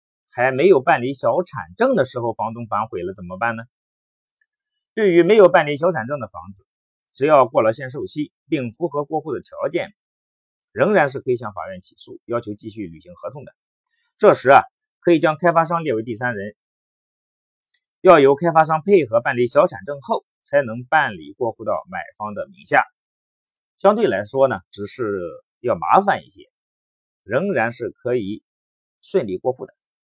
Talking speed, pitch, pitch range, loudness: 255 characters per minute, 135 Hz, 110-170 Hz, -19 LUFS